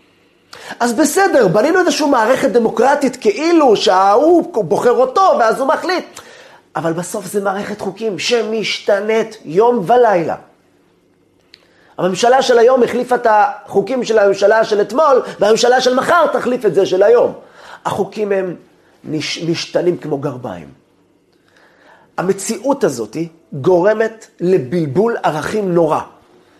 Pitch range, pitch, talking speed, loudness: 185-255 Hz, 220 Hz, 115 wpm, -14 LUFS